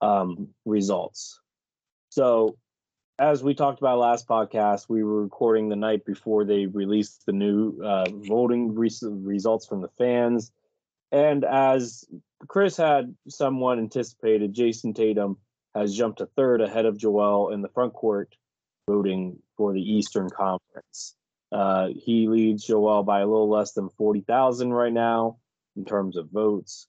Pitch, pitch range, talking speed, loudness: 110 Hz, 100-120 Hz, 145 wpm, -24 LUFS